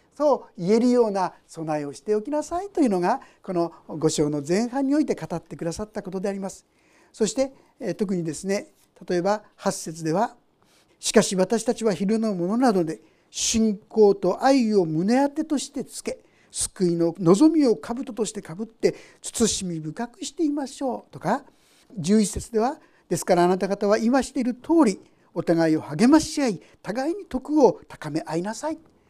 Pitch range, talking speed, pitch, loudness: 180-260 Hz, 330 characters per minute, 215 Hz, -24 LUFS